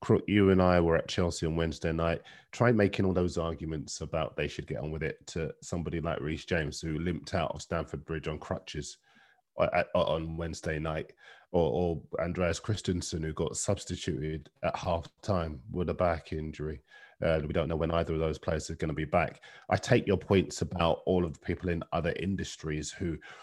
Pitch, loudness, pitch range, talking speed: 85 Hz, -31 LUFS, 80-90 Hz, 200 wpm